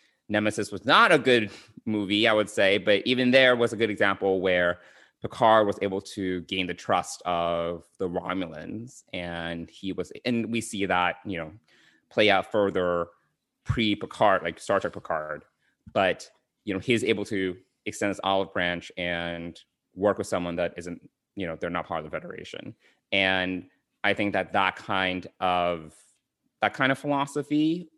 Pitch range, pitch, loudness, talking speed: 90-110 Hz, 95 Hz, -26 LUFS, 170 wpm